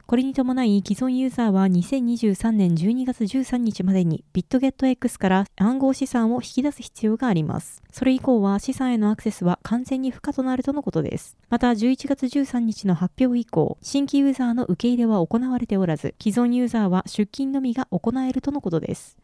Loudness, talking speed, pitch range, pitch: -22 LUFS, 375 characters per minute, 205-260 Hz, 240 Hz